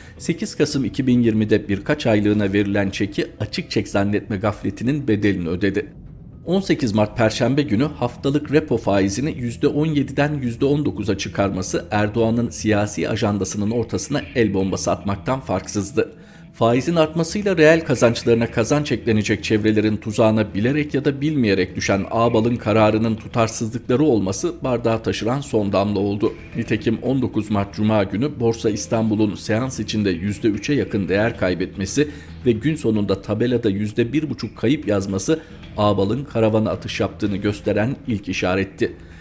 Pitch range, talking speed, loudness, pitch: 100-130 Hz, 120 wpm, -20 LUFS, 110 Hz